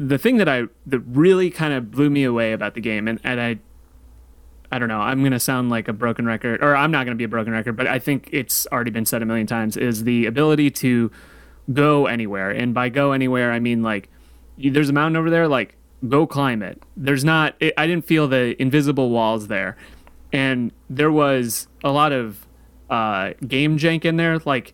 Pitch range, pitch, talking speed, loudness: 115-145 Hz, 125 Hz, 220 wpm, -20 LUFS